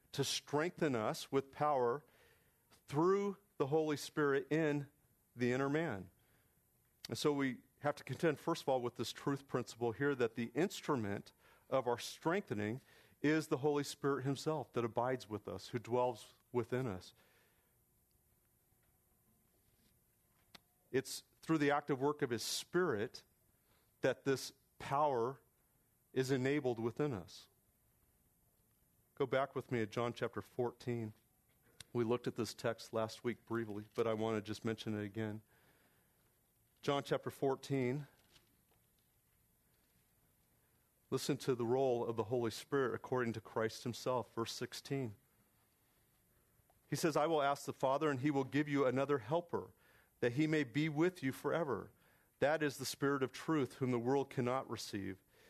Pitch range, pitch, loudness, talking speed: 115-145 Hz, 130 Hz, -39 LUFS, 145 wpm